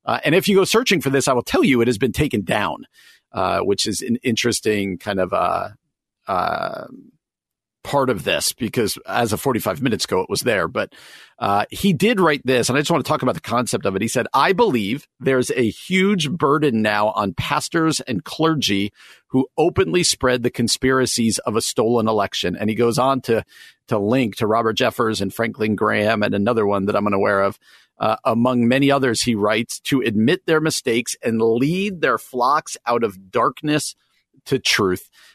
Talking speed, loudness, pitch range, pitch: 200 wpm, -19 LUFS, 105-140 Hz, 120 Hz